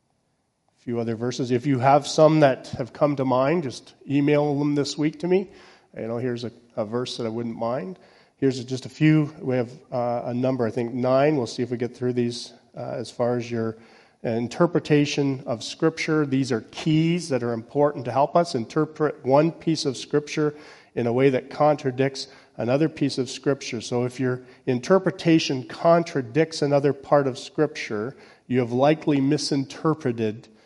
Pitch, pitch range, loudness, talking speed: 135 Hz, 125-150 Hz, -24 LUFS, 180 wpm